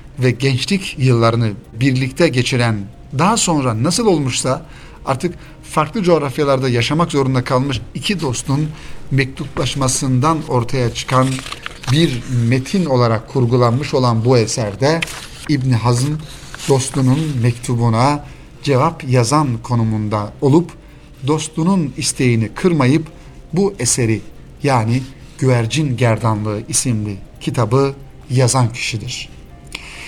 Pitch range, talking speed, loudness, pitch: 120-150 Hz, 95 wpm, -17 LUFS, 130 Hz